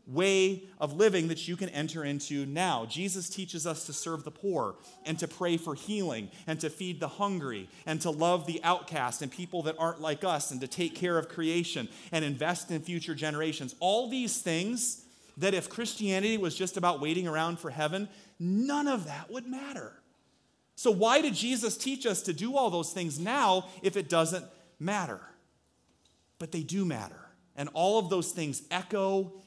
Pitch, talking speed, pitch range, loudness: 175 Hz, 185 wpm, 155-195 Hz, -31 LUFS